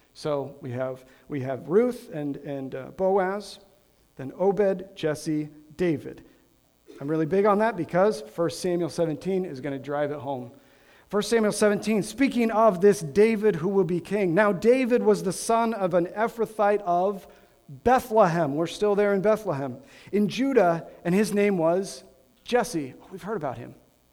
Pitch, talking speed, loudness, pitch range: 185 Hz, 165 wpm, -25 LUFS, 145-210 Hz